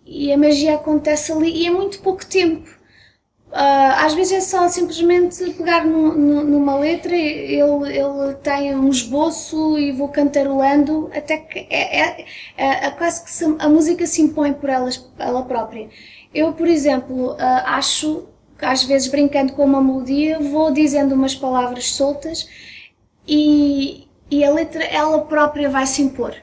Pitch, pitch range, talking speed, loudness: 295 Hz, 275-320 Hz, 155 wpm, -17 LUFS